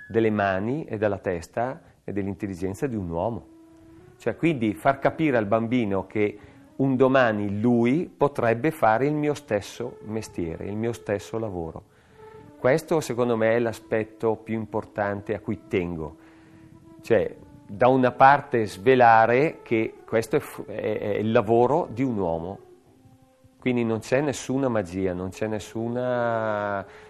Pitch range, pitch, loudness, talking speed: 105-130 Hz, 115 Hz, -24 LUFS, 140 wpm